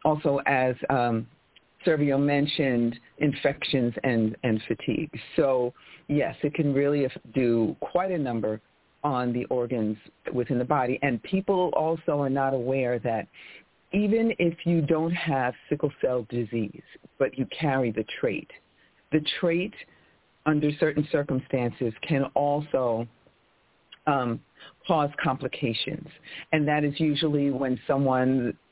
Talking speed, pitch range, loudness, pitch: 125 wpm, 120-150 Hz, -27 LUFS, 135 Hz